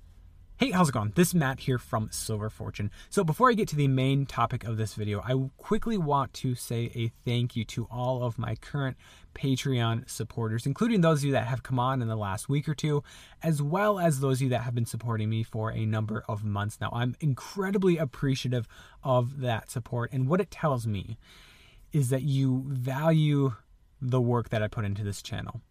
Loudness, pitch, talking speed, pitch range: -29 LUFS, 125 Hz, 210 wpm, 110-140 Hz